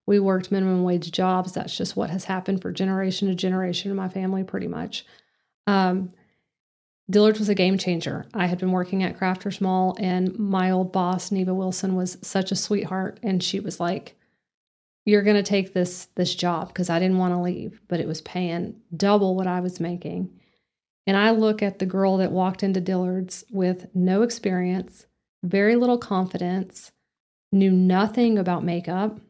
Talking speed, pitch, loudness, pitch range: 180 wpm, 185 Hz, -24 LUFS, 180-200 Hz